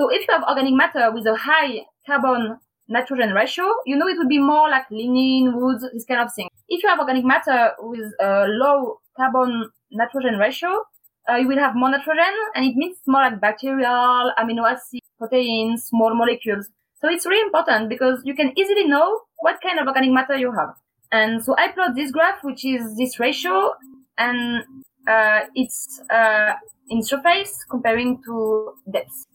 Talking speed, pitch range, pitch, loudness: 180 wpm, 230-295 Hz, 260 Hz, -19 LUFS